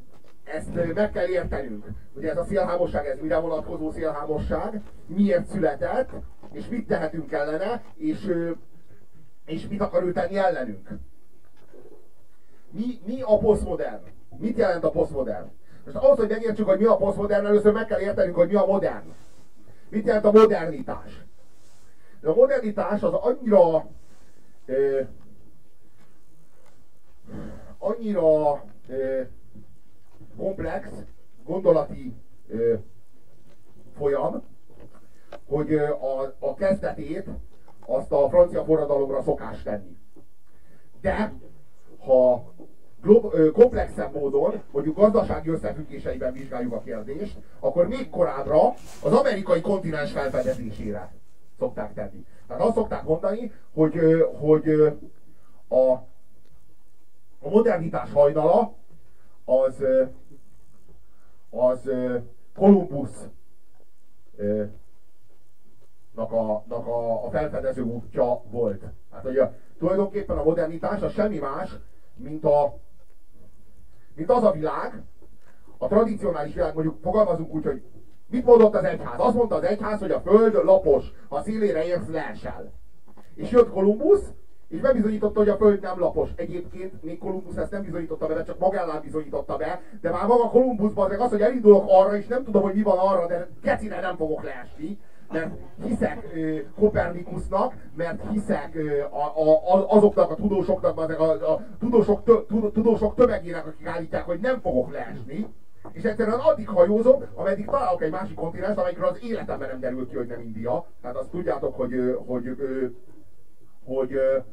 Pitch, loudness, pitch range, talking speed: 175 Hz, -23 LUFS, 135-210 Hz, 130 wpm